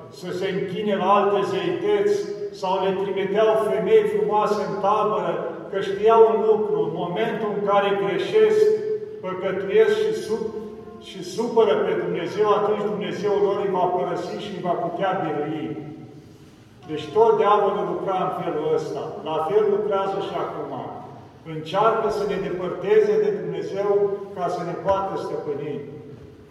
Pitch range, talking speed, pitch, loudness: 185-225 Hz, 145 wpm, 200 Hz, -22 LUFS